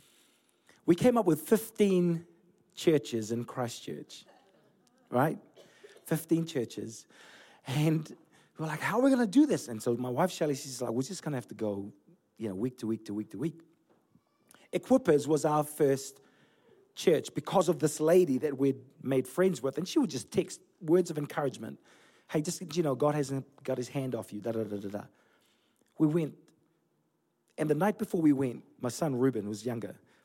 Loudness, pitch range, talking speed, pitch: -31 LUFS, 125-170 Hz, 190 wpm, 150 Hz